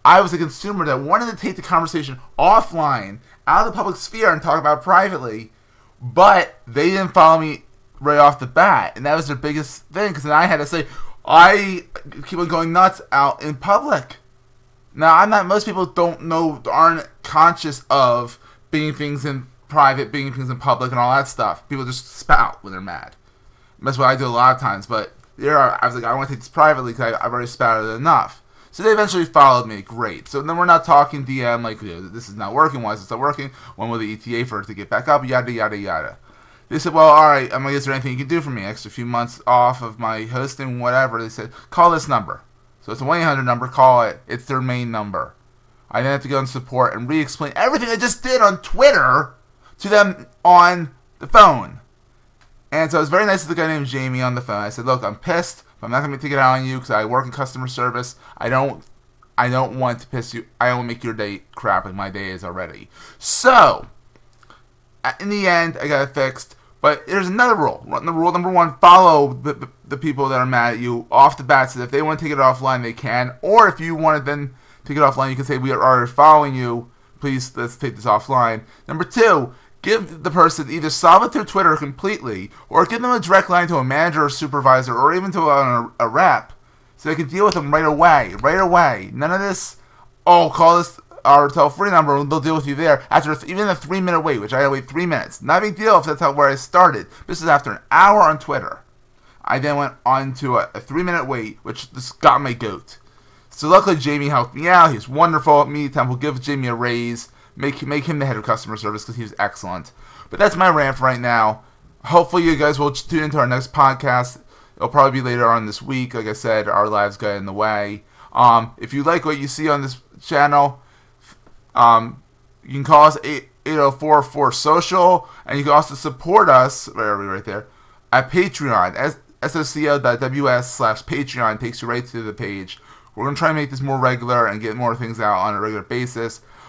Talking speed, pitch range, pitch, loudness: 230 wpm, 120-155 Hz, 135 Hz, -16 LUFS